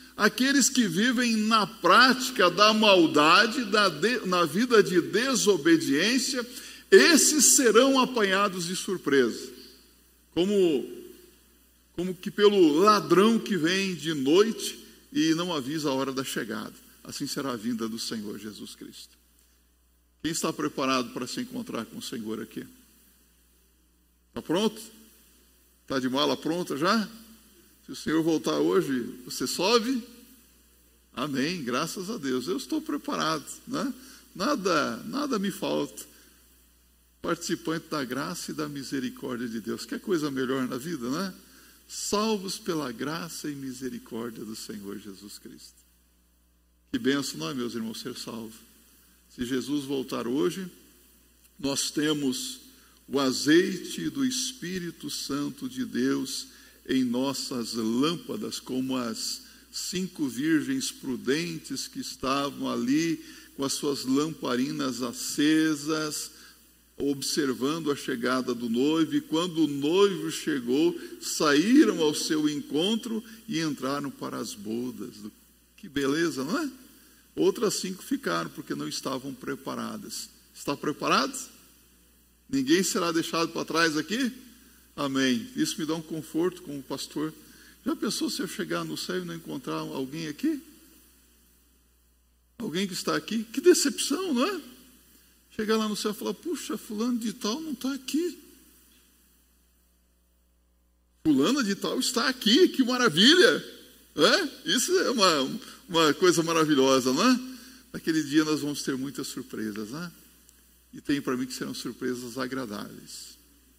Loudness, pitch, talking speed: -26 LUFS, 165 Hz, 130 wpm